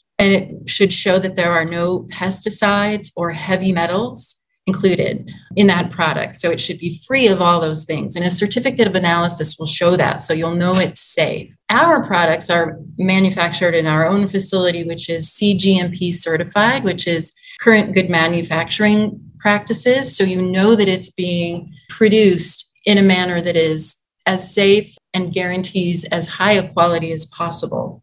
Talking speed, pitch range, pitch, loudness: 165 wpm, 170-200 Hz, 180 Hz, -15 LUFS